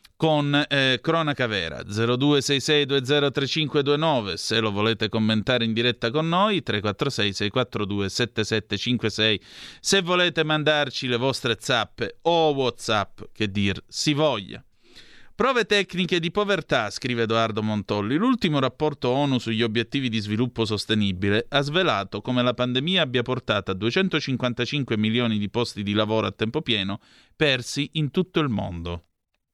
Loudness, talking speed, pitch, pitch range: -23 LUFS, 130 wpm, 125 Hz, 110-145 Hz